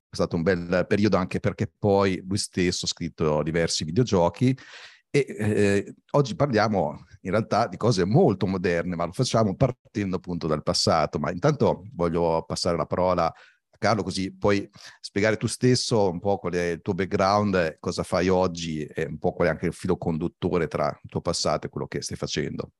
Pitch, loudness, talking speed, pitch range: 95 Hz, -25 LUFS, 190 wpm, 85-105 Hz